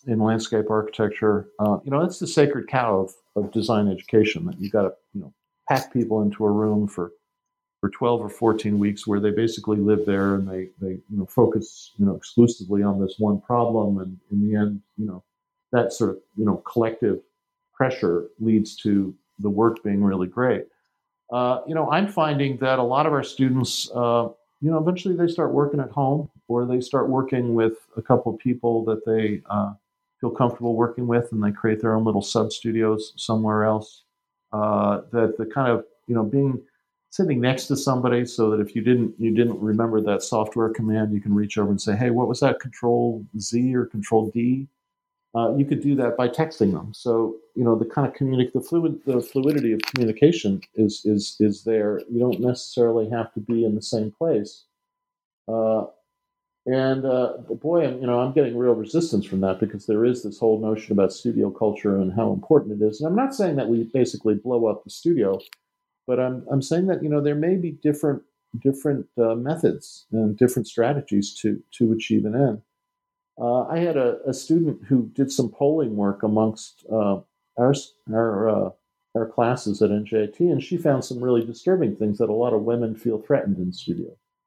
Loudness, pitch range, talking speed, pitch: -23 LUFS, 110-140 Hz, 200 wpm, 115 Hz